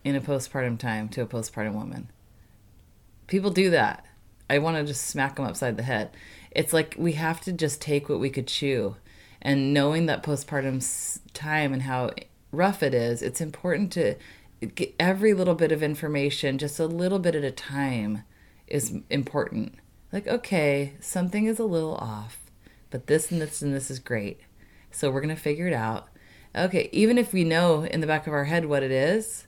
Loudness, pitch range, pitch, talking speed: -26 LUFS, 115-160 Hz, 140 Hz, 195 wpm